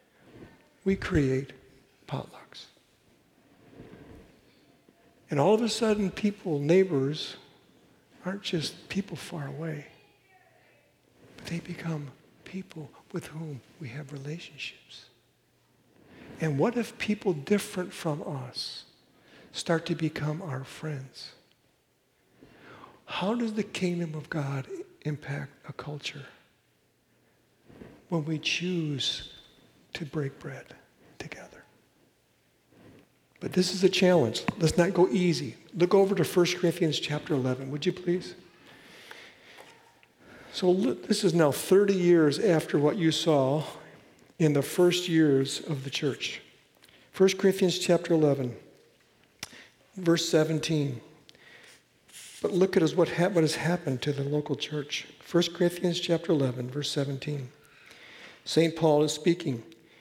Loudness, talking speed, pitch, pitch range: -28 LUFS, 115 wpm, 160 Hz, 145-180 Hz